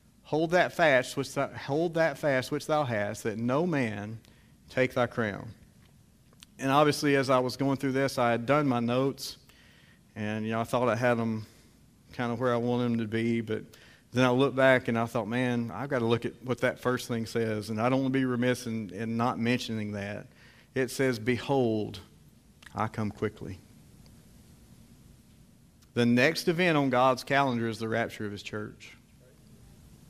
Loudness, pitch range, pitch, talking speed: -29 LUFS, 115-135 Hz, 120 Hz, 190 wpm